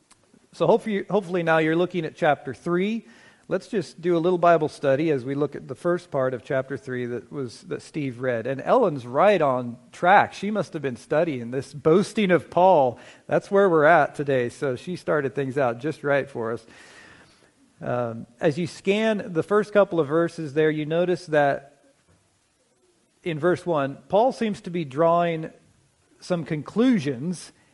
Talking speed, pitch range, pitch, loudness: 175 wpm, 140-180 Hz, 160 Hz, -23 LUFS